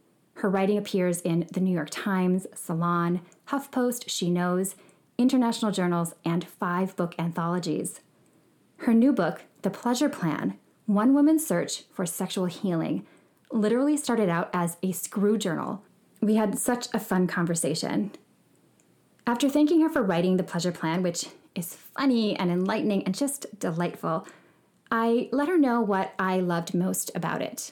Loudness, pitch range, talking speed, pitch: -27 LUFS, 175-235 Hz, 150 wpm, 190 Hz